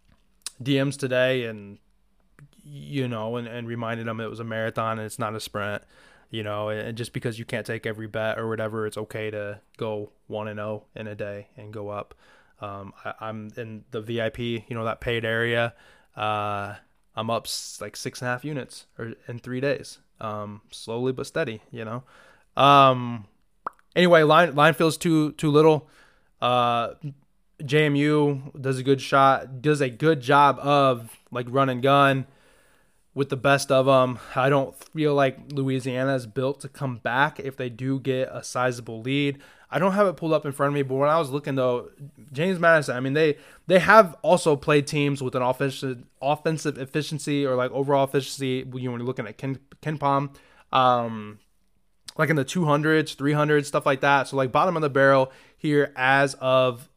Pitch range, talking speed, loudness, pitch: 115-145 Hz, 190 wpm, -23 LUFS, 130 Hz